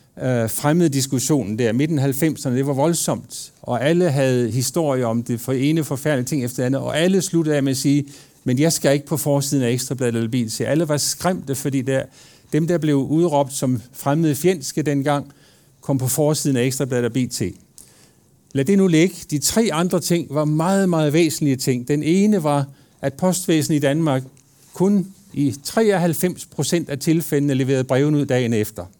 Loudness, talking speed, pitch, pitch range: -20 LUFS, 180 wpm, 145 Hz, 135-160 Hz